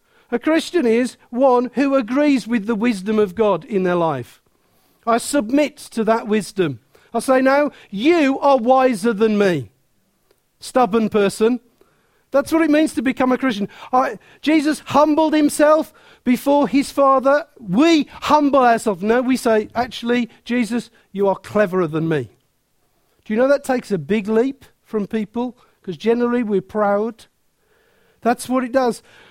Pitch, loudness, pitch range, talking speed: 240 Hz, -18 LUFS, 215-275 Hz, 155 wpm